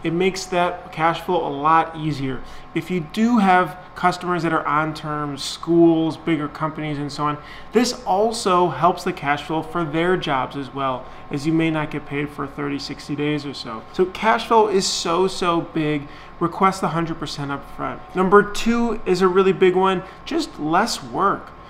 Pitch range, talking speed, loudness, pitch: 150-185 Hz, 190 wpm, -21 LUFS, 165 Hz